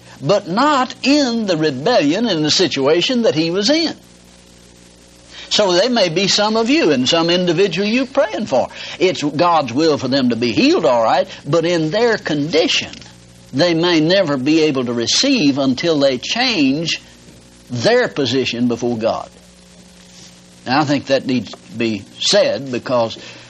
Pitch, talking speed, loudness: 155 Hz, 160 wpm, -16 LUFS